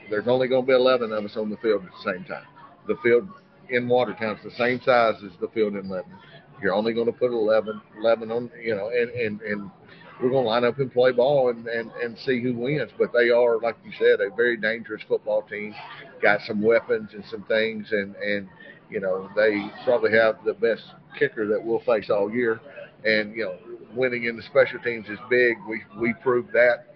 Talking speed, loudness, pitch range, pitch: 225 wpm, -24 LUFS, 110-130 Hz, 120 Hz